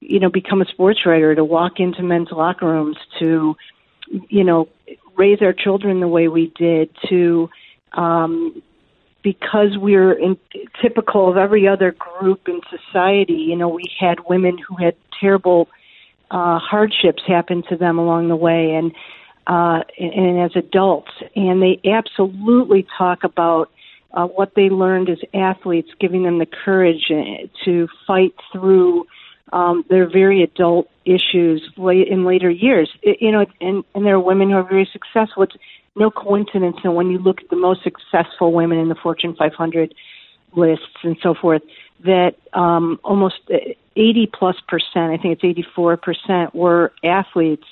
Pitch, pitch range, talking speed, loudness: 180 Hz, 170-195 Hz, 165 wpm, -16 LUFS